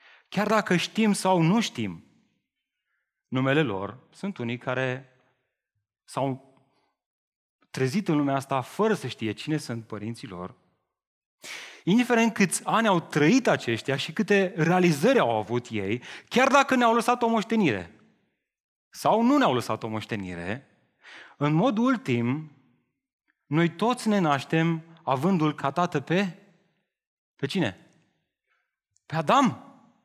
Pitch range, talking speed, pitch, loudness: 125-205 Hz, 125 wpm, 155 Hz, -25 LUFS